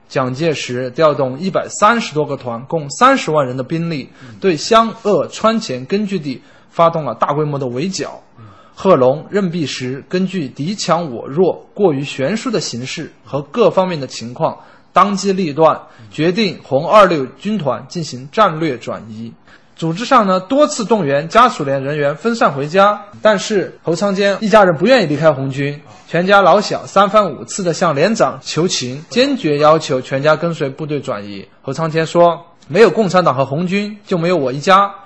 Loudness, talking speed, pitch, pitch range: -15 LUFS, 265 characters per minute, 165 Hz, 135-200 Hz